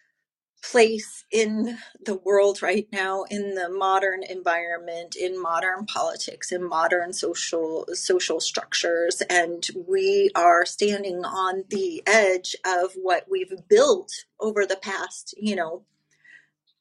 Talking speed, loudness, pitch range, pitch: 120 wpm, -24 LUFS, 180-220 Hz, 190 Hz